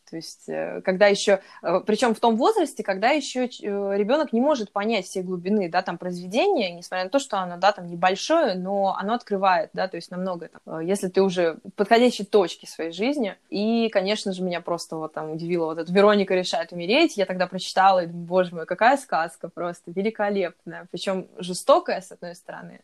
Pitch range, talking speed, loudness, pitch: 175-215 Hz, 190 wpm, -23 LUFS, 190 Hz